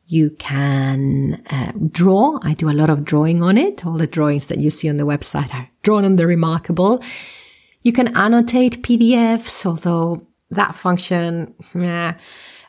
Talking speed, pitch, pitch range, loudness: 160 wpm, 170 Hz, 155-200 Hz, -17 LUFS